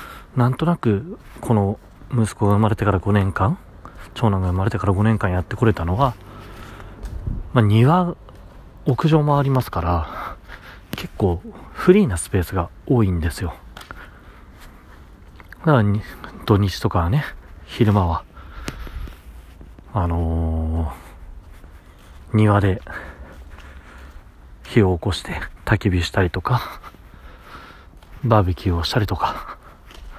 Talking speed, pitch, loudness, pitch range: 215 characters per minute, 95 Hz, -20 LUFS, 80-110 Hz